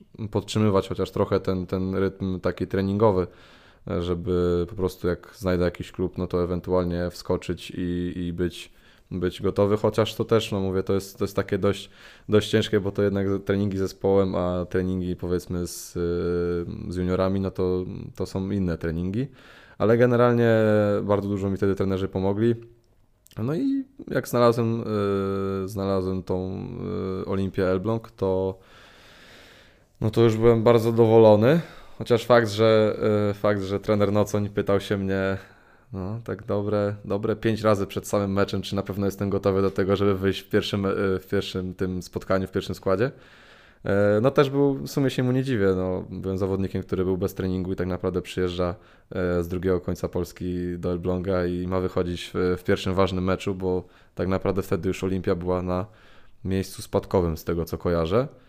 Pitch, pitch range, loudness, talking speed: 95 Hz, 90-105 Hz, -25 LUFS, 165 wpm